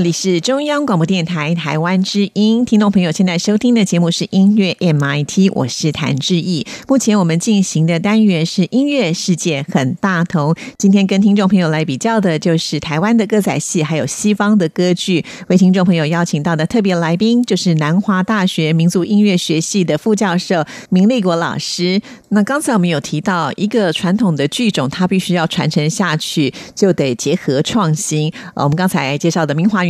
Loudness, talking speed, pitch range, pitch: -14 LUFS, 305 characters per minute, 160-205 Hz, 180 Hz